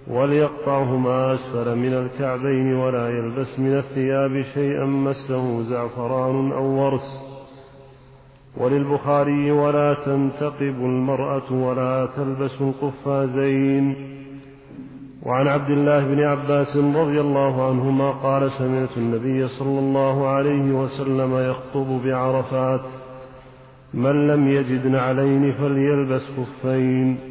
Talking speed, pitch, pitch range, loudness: 95 wpm, 135 Hz, 130-140 Hz, -21 LUFS